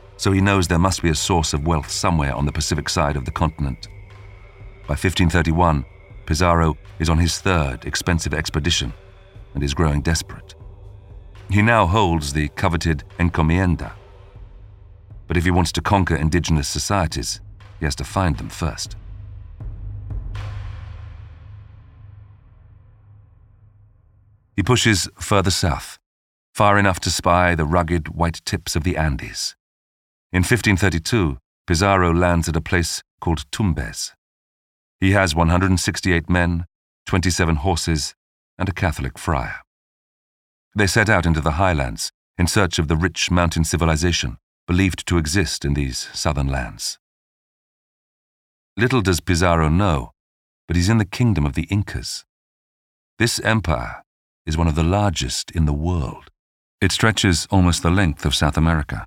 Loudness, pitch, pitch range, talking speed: -20 LUFS, 90 Hz, 80-100 Hz, 135 wpm